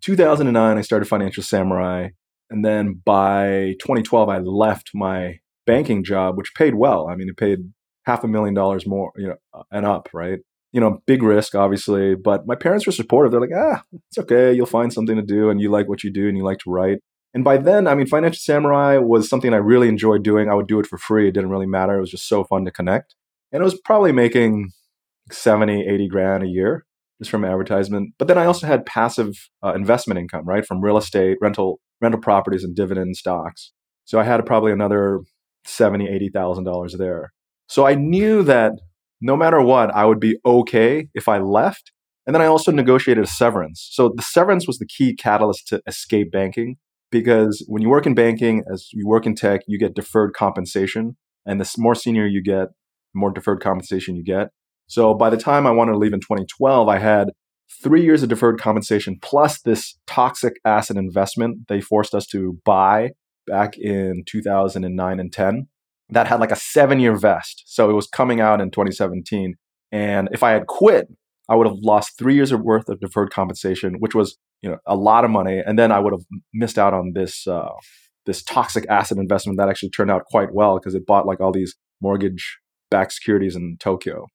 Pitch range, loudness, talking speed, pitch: 95-115 Hz, -18 LUFS, 205 wpm, 105 Hz